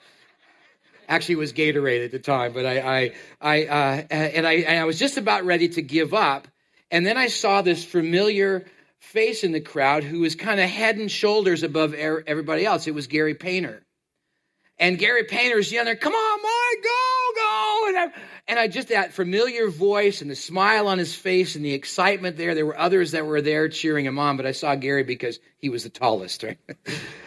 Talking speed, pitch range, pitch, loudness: 205 wpm, 150-215 Hz, 175 Hz, -22 LUFS